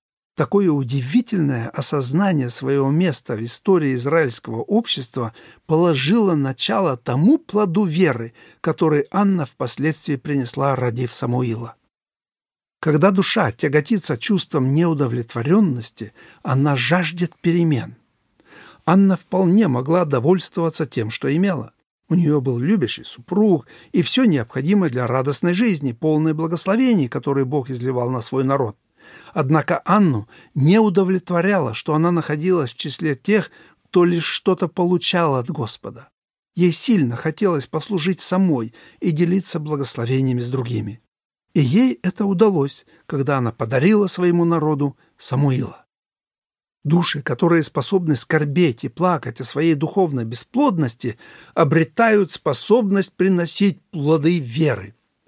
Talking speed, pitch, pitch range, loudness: 115 wpm, 160 Hz, 135-180 Hz, -19 LUFS